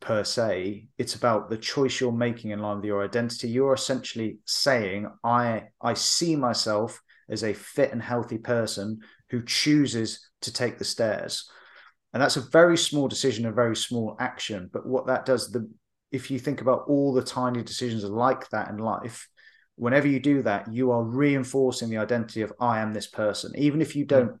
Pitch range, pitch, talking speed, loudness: 110-135 Hz, 120 Hz, 190 wpm, -26 LUFS